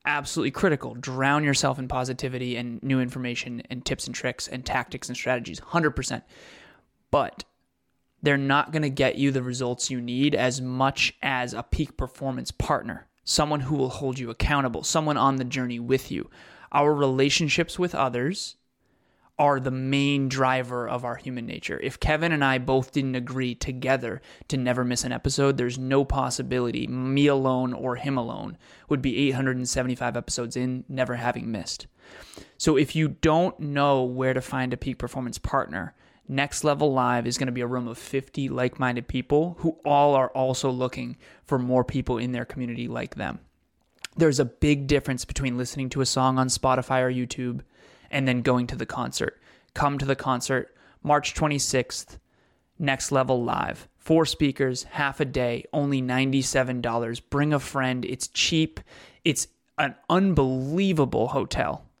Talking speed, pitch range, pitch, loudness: 165 wpm, 125-140 Hz, 130 Hz, -25 LUFS